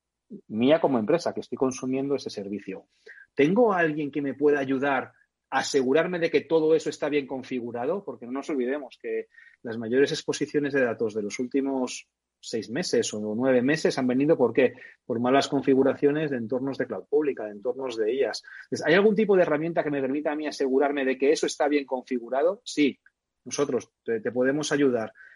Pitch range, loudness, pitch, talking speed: 130-155 Hz, -26 LUFS, 140 Hz, 185 wpm